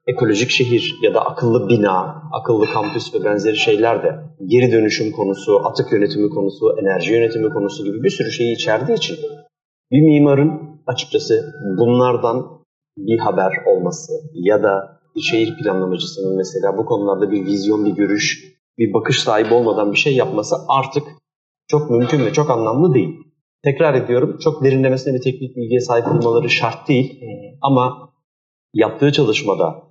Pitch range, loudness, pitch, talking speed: 115-155 Hz, -17 LUFS, 130 Hz, 150 wpm